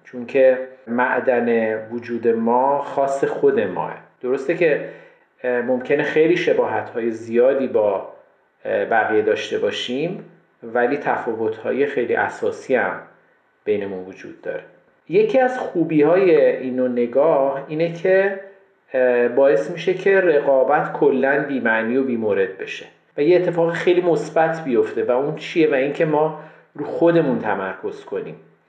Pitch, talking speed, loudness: 175 Hz, 130 wpm, -19 LUFS